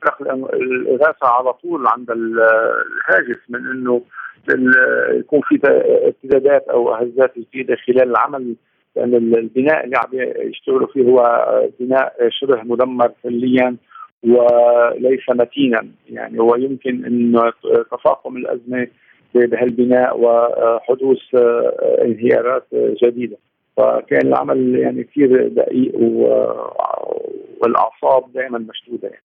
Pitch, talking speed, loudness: 125 Hz, 95 wpm, -15 LUFS